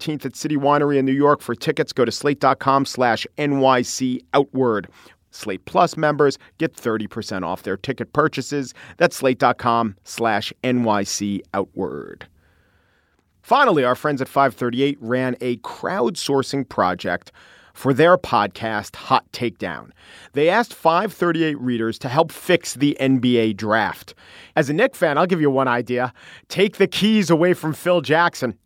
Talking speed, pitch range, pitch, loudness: 140 wpm, 120-155 Hz, 135 Hz, -20 LUFS